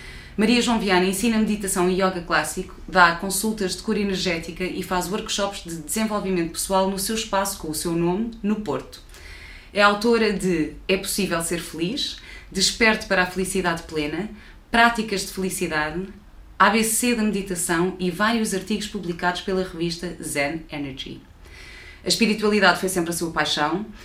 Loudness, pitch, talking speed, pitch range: -22 LUFS, 185 Hz, 150 wpm, 170-205 Hz